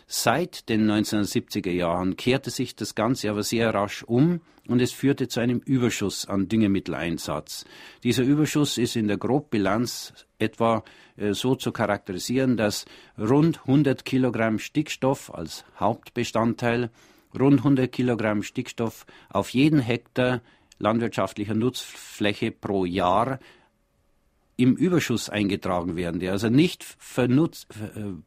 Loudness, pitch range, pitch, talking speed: -25 LUFS, 100-125 Hz, 115 Hz, 120 wpm